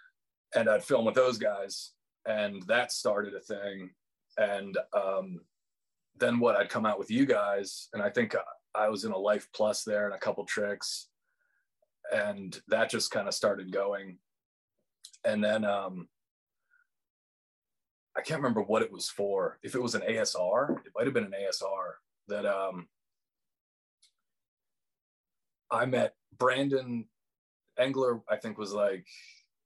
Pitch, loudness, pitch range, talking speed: 105 Hz, -31 LUFS, 100-135 Hz, 150 wpm